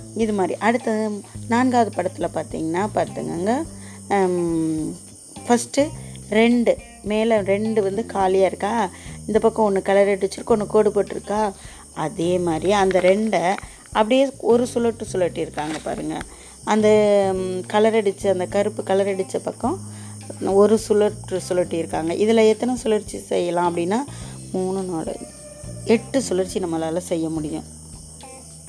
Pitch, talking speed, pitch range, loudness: 195 Hz, 115 wpm, 165-215 Hz, -21 LUFS